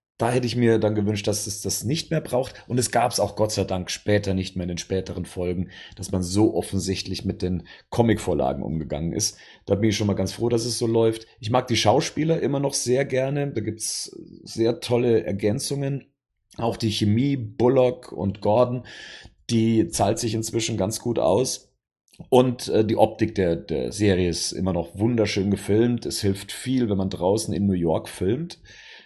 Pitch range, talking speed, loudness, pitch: 95-120 Hz, 200 wpm, -24 LUFS, 110 Hz